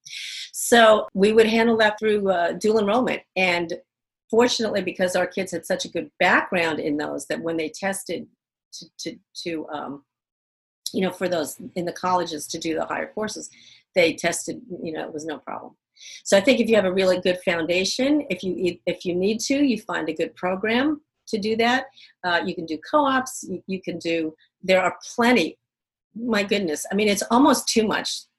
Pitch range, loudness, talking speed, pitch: 170-220 Hz, -22 LUFS, 195 wpm, 185 Hz